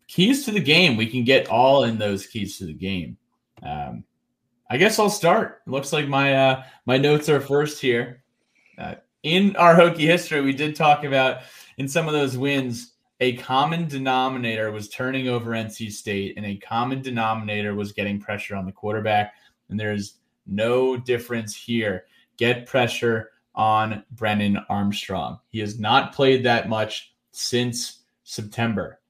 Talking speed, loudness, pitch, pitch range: 165 wpm, -22 LUFS, 120 Hz, 105-135 Hz